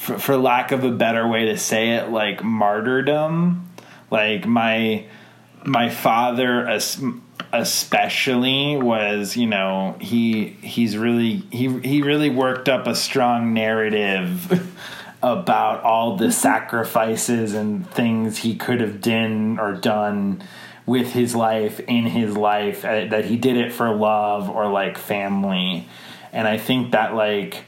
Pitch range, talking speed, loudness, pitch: 105-125 Hz, 135 wpm, -20 LUFS, 115 Hz